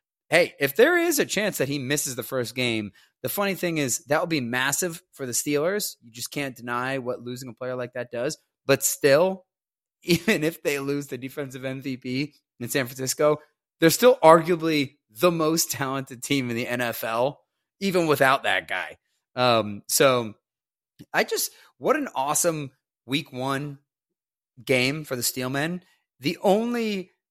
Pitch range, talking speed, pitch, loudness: 125-165 Hz, 165 wpm, 140 Hz, -24 LUFS